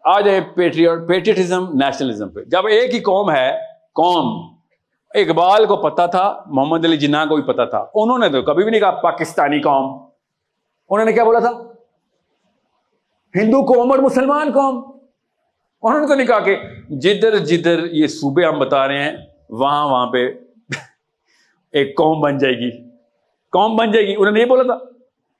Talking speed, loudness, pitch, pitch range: 170 wpm, -16 LUFS, 195 Hz, 150-240 Hz